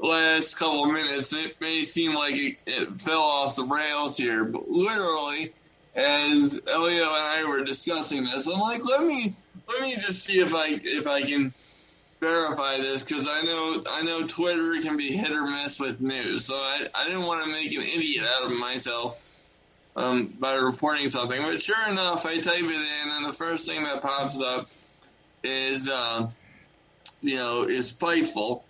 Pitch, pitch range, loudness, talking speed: 155 Hz, 135-170 Hz, -25 LUFS, 185 wpm